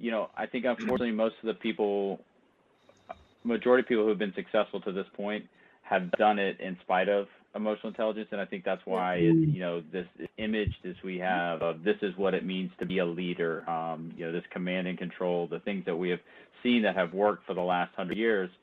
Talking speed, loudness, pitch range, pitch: 230 wpm, -30 LUFS, 90-110 Hz, 95 Hz